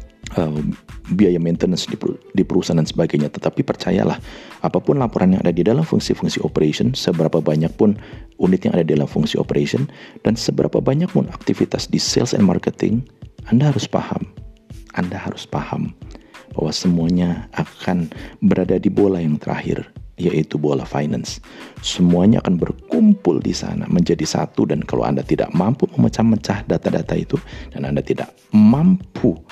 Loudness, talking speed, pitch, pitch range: -19 LUFS, 145 wpm, 90 Hz, 80-115 Hz